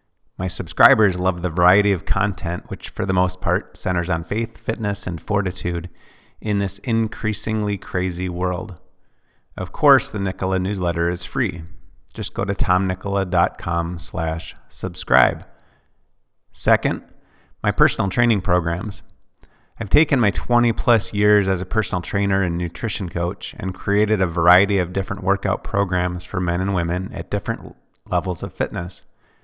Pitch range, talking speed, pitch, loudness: 90-105 Hz, 145 wpm, 95 Hz, -21 LUFS